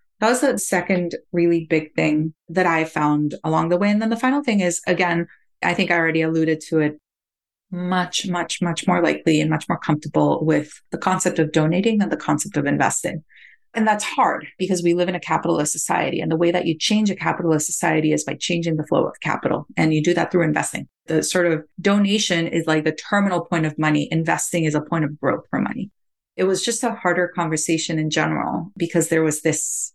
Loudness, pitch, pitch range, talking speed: -20 LUFS, 170 Hz, 160-180 Hz, 220 wpm